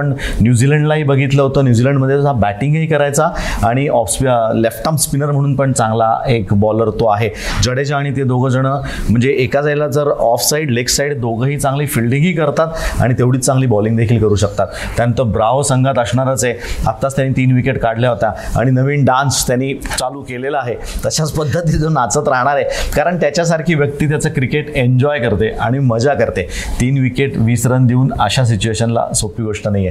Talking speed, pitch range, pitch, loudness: 175 wpm, 115-140 Hz, 130 Hz, -14 LUFS